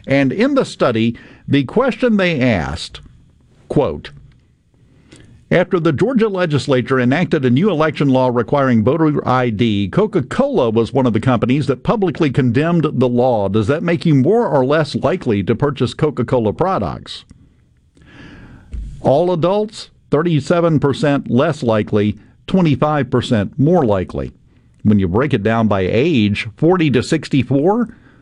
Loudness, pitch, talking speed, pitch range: -16 LUFS, 135 Hz, 130 wpm, 120-160 Hz